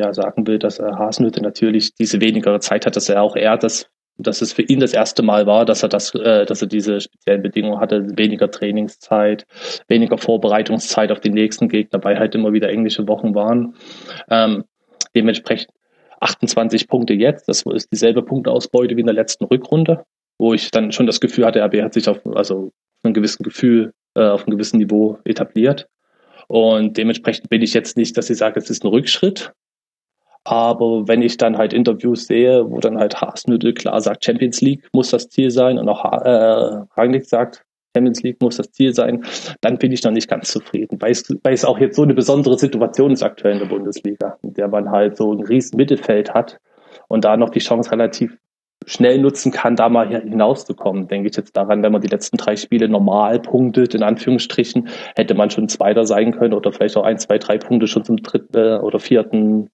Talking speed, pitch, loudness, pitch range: 200 wpm, 110 Hz, -16 LUFS, 105-120 Hz